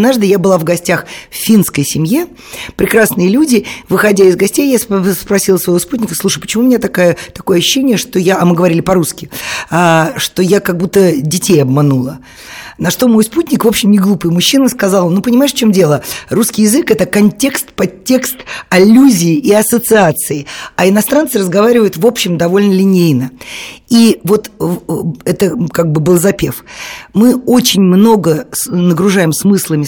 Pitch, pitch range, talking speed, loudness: 195 Hz, 175-220 Hz, 160 wpm, -10 LUFS